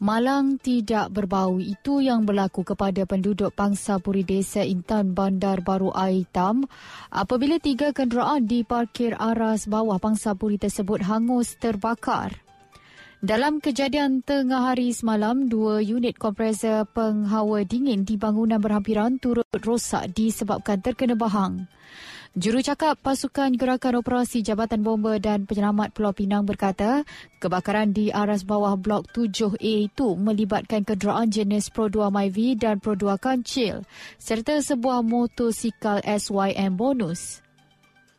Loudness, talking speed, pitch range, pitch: -24 LUFS, 120 wpm, 205-240 Hz, 215 Hz